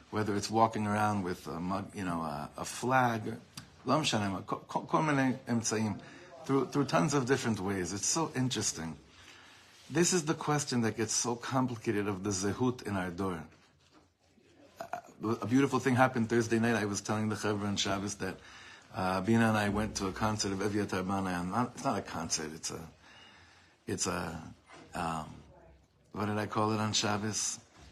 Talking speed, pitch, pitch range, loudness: 165 wpm, 105 Hz, 95-120 Hz, -32 LUFS